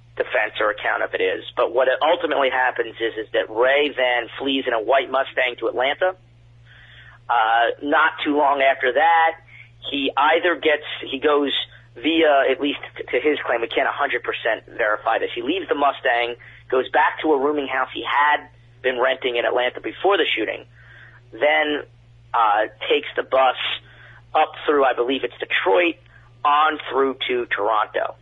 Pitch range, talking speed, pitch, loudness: 120-165 Hz, 165 wpm, 140 Hz, -20 LUFS